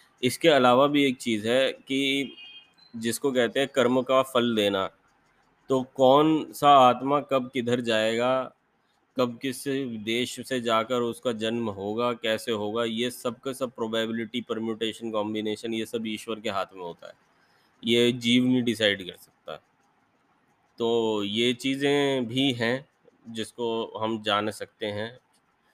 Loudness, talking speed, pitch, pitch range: -25 LUFS, 140 wpm, 120 Hz, 115-130 Hz